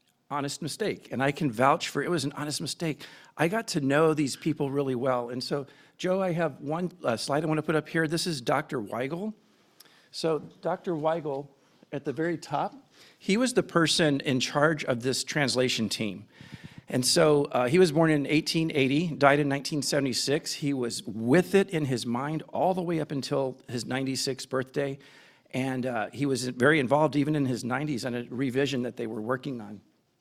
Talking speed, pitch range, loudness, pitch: 195 wpm, 130-160 Hz, -28 LUFS, 145 Hz